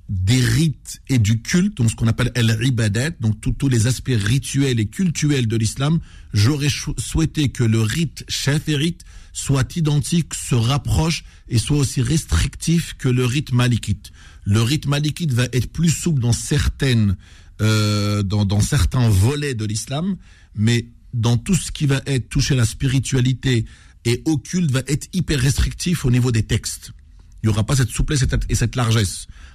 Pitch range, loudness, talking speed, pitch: 110-145 Hz, -20 LUFS, 175 wpm, 125 Hz